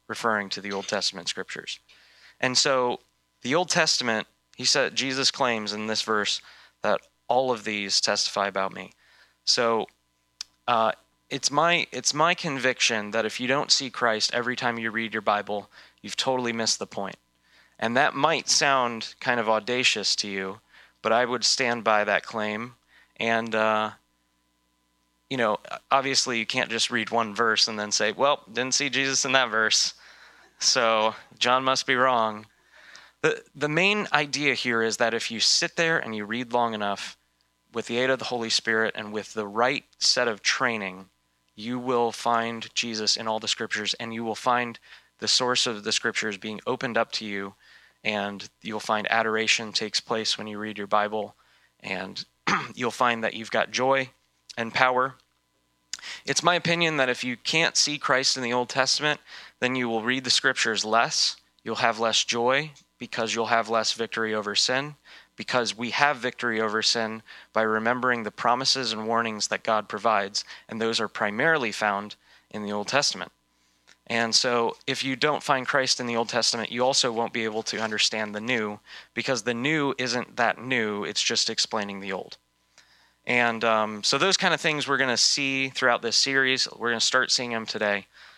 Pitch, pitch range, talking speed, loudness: 115 Hz, 110-130 Hz, 185 wpm, -24 LUFS